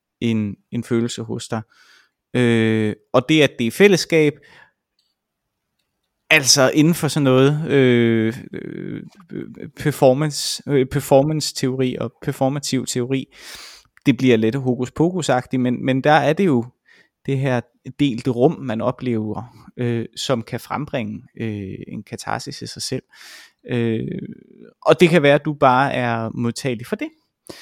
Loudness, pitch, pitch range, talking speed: -19 LUFS, 130 Hz, 120-145 Hz, 135 wpm